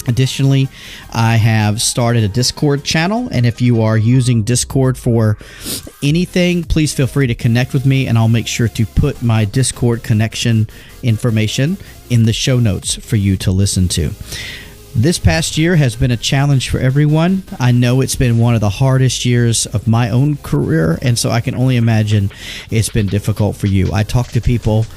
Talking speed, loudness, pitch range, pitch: 185 wpm, -14 LUFS, 110-130 Hz, 120 Hz